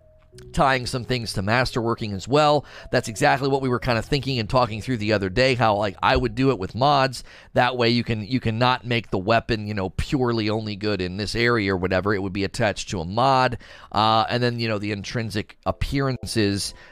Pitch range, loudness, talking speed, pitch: 105-125 Hz, -22 LUFS, 225 wpm, 115 Hz